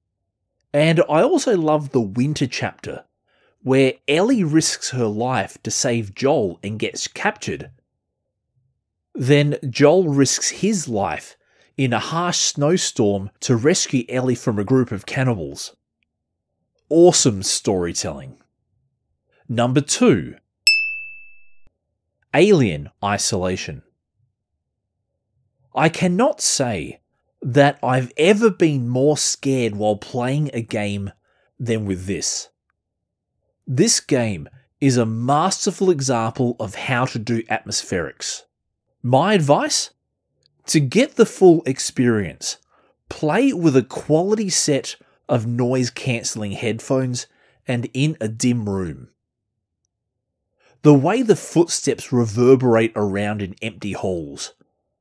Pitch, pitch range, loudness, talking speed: 125 Hz, 110-150 Hz, -19 LUFS, 105 wpm